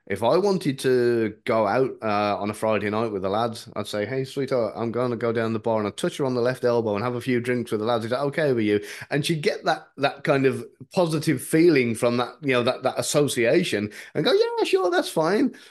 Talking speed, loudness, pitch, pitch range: 260 wpm, -23 LUFS, 125 Hz, 110-140 Hz